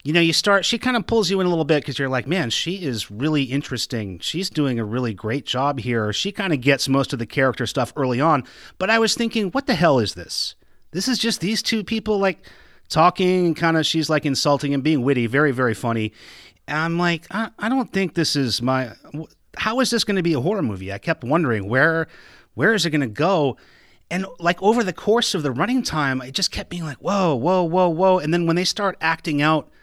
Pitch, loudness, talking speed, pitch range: 160 Hz, -21 LUFS, 245 wpm, 130-190 Hz